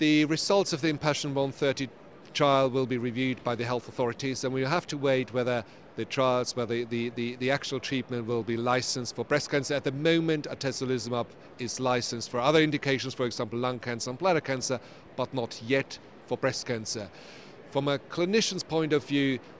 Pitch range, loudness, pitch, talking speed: 120-145 Hz, -29 LUFS, 130 Hz, 195 wpm